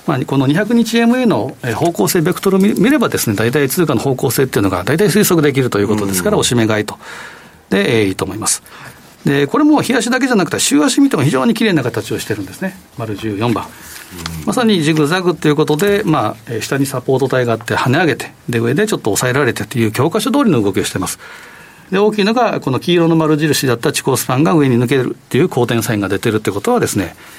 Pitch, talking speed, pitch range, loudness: 145 Hz, 465 characters per minute, 115-190 Hz, -14 LUFS